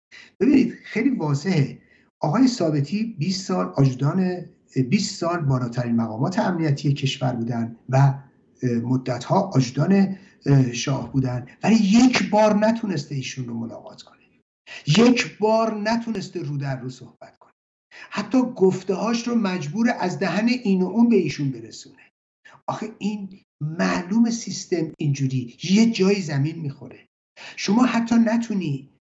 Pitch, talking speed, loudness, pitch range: 175 Hz, 130 wpm, -22 LUFS, 135-215 Hz